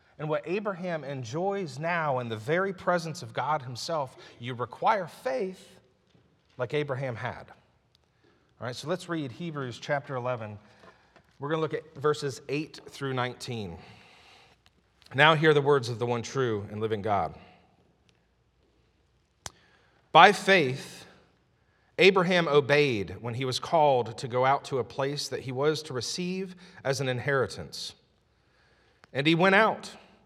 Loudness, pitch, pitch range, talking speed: -27 LUFS, 140 Hz, 125-165 Hz, 145 wpm